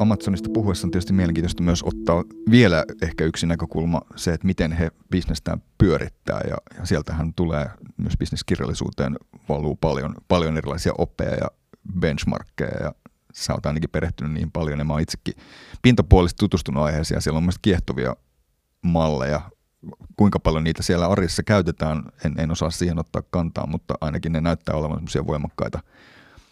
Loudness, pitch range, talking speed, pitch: -23 LUFS, 75-90 Hz, 145 wpm, 85 Hz